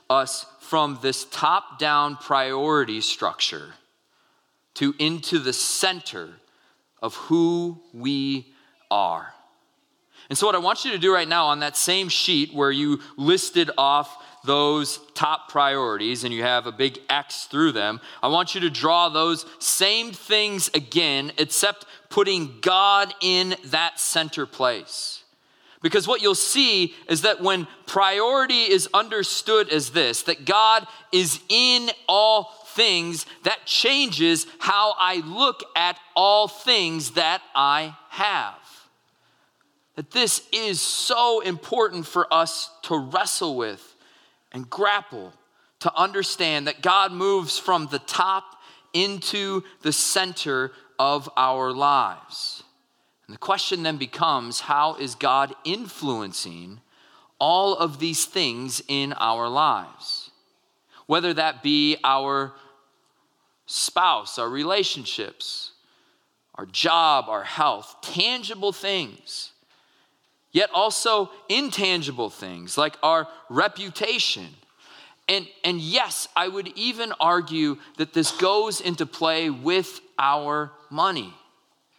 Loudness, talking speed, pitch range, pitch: -22 LUFS, 120 wpm, 145-195 Hz, 170 Hz